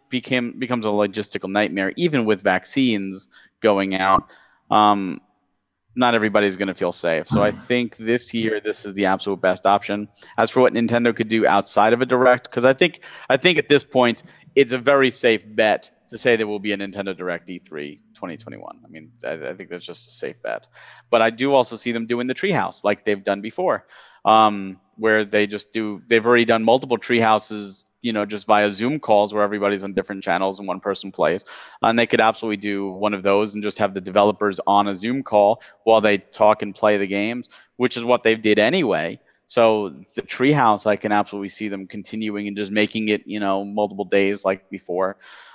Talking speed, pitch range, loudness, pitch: 210 wpm, 100-115 Hz, -20 LUFS, 105 Hz